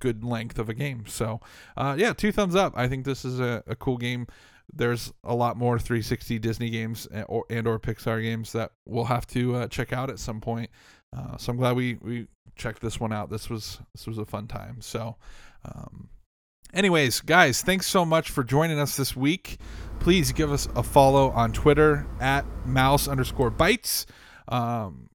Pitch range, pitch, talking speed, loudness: 115-135 Hz, 120 Hz, 200 wpm, -25 LUFS